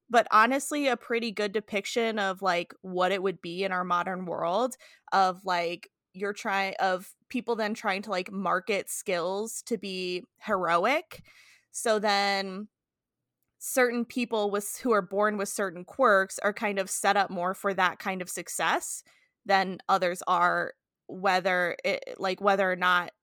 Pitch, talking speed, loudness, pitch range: 195 Hz, 160 wpm, -28 LUFS, 185-215 Hz